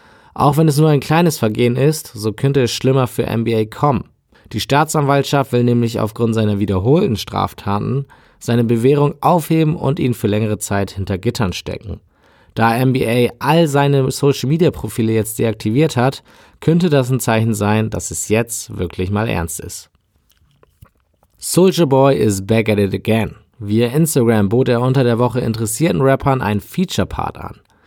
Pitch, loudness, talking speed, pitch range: 120 Hz, -16 LUFS, 165 wpm, 105-140 Hz